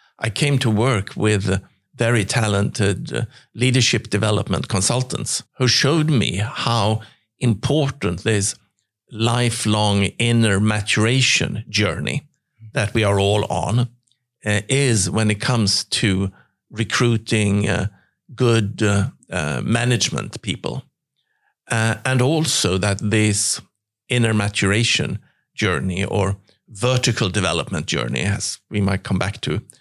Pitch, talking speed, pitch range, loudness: 110 Hz, 115 wpm, 100-120 Hz, -19 LUFS